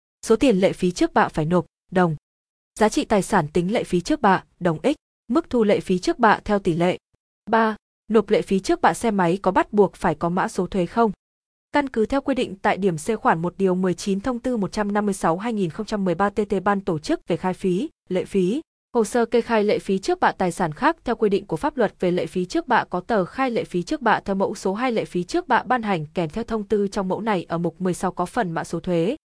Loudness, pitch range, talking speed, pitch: -22 LUFS, 180-225 Hz, 255 wpm, 195 Hz